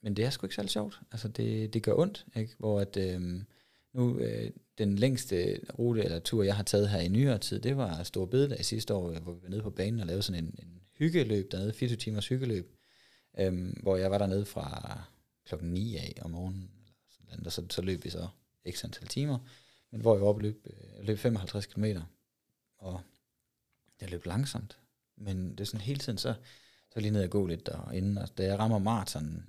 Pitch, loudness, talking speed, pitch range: 105 Hz, -33 LUFS, 225 wpm, 95-115 Hz